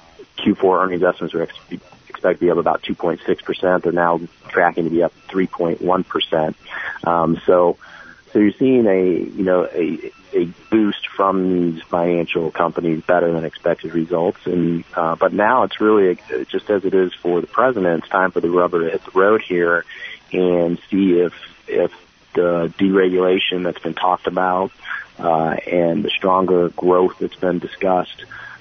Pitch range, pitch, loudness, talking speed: 85-95 Hz, 90 Hz, -18 LUFS, 165 wpm